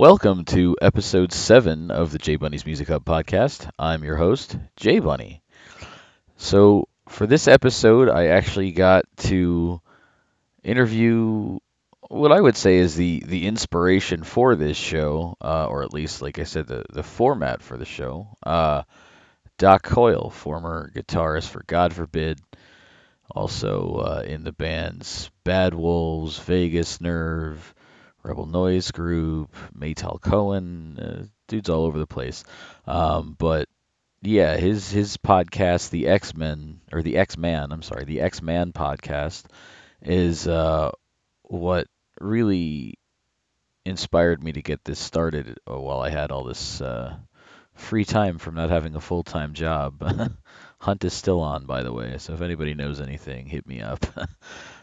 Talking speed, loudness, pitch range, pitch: 150 wpm, -22 LUFS, 80-95 Hz, 85 Hz